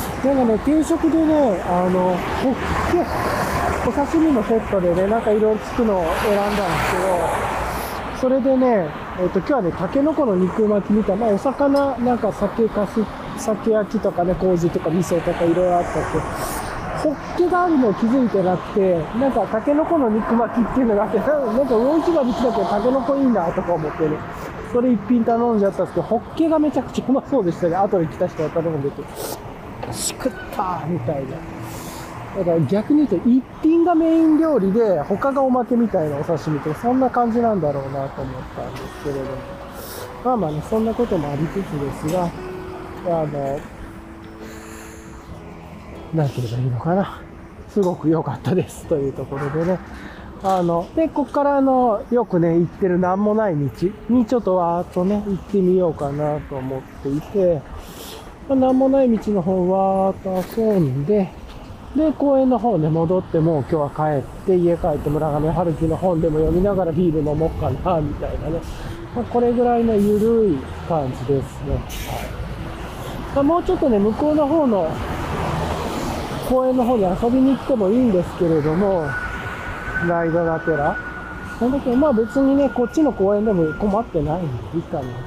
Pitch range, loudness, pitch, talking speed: 165-245 Hz, -20 LUFS, 195 Hz, 340 characters per minute